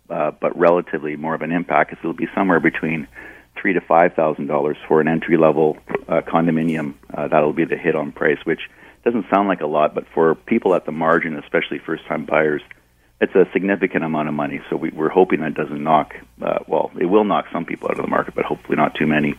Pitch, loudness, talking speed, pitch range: 80 Hz, -19 LUFS, 230 wpm, 75-80 Hz